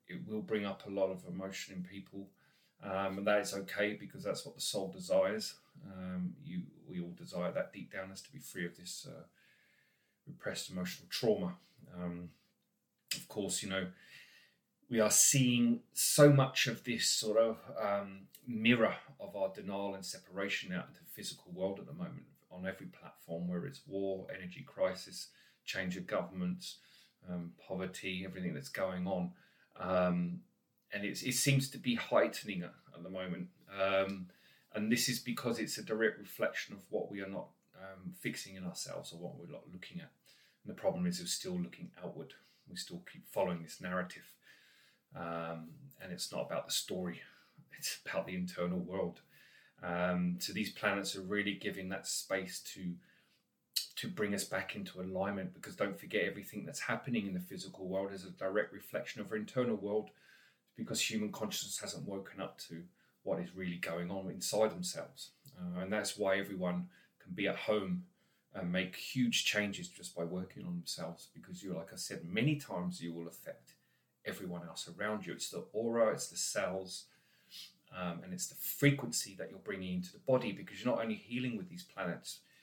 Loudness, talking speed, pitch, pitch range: -37 LUFS, 185 wpm, 100 Hz, 90-135 Hz